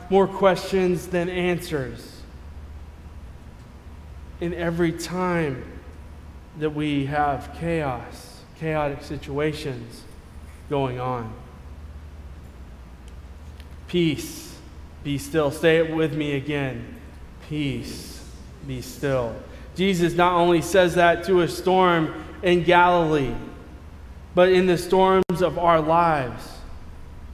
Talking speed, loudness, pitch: 95 wpm, -22 LUFS, 140 Hz